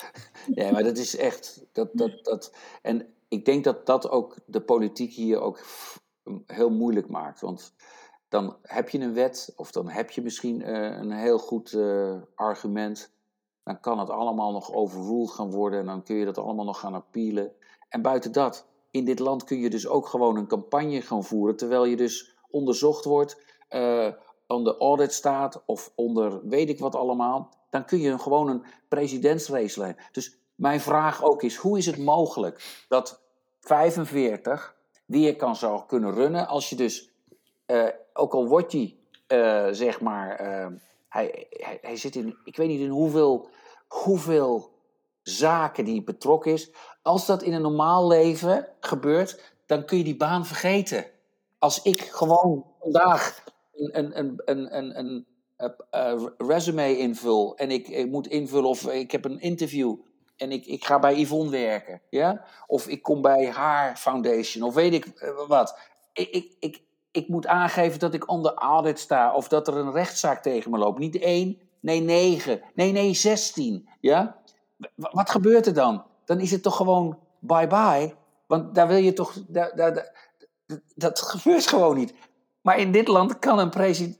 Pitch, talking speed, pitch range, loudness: 145 Hz, 175 wpm, 120-175 Hz, -25 LUFS